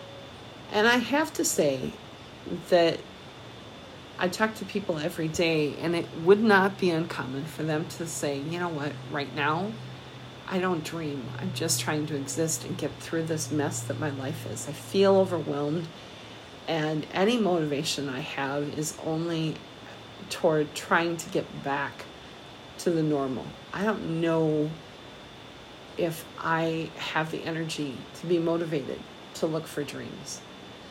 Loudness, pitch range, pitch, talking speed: -28 LUFS, 145-170 Hz, 160 Hz, 150 wpm